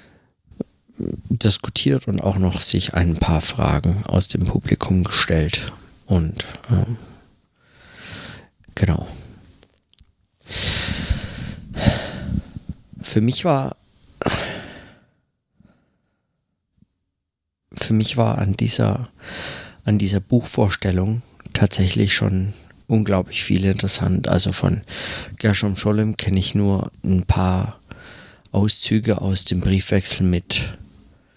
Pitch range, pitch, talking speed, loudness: 90-110 Hz, 100 Hz, 85 wpm, -20 LUFS